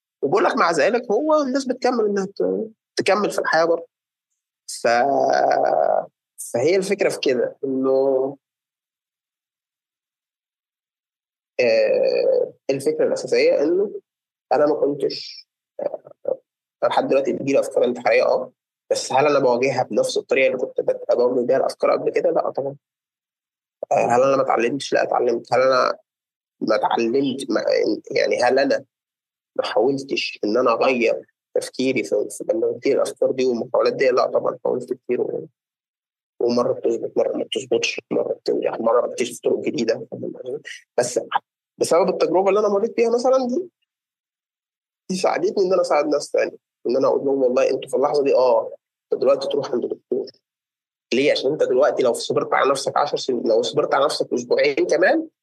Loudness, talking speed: -20 LUFS, 145 wpm